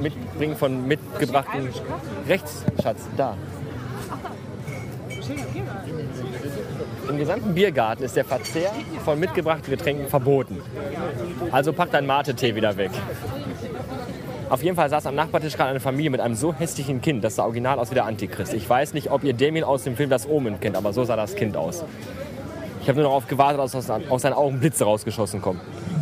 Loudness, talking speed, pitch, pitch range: -24 LUFS, 165 wpm, 135 Hz, 120-150 Hz